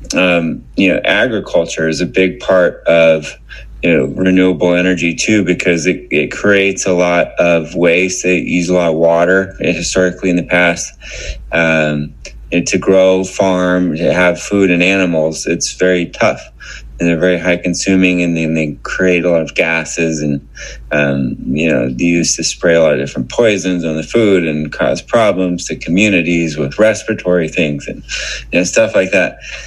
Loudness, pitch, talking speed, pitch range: -13 LUFS, 90 Hz, 180 wpm, 80-90 Hz